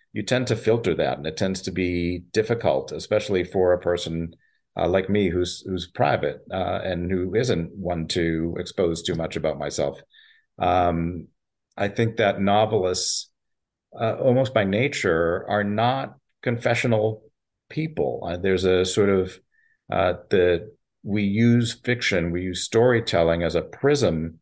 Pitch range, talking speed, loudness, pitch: 85-110 Hz, 150 wpm, -23 LUFS, 95 Hz